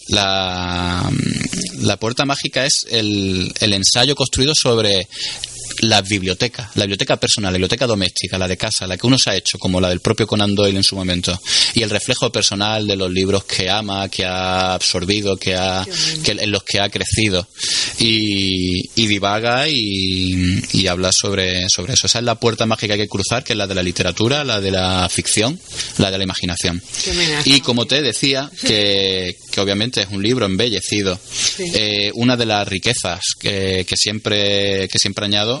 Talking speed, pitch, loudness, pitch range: 185 wpm, 100 Hz, -16 LUFS, 95-115 Hz